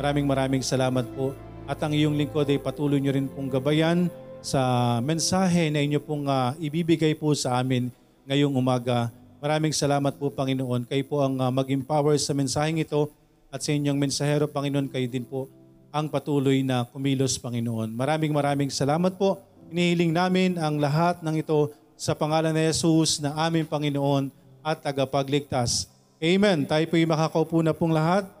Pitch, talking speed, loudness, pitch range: 145 Hz, 165 wpm, -25 LUFS, 135-155 Hz